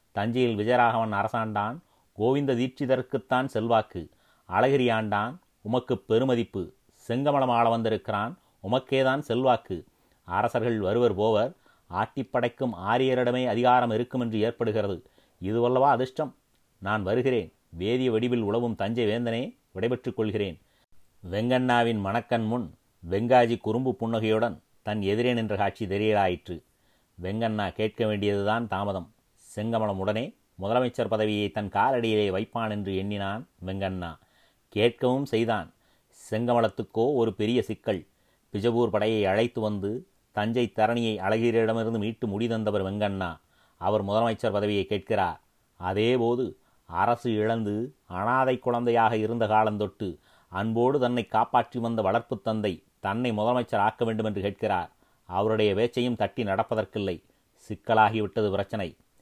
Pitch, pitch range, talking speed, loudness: 110 Hz, 105-120 Hz, 105 wpm, -27 LUFS